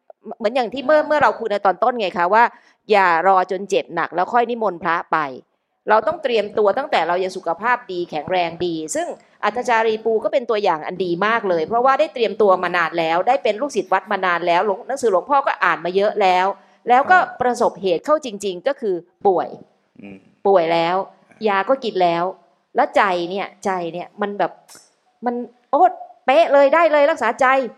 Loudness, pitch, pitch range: -18 LUFS, 205 Hz, 180-245 Hz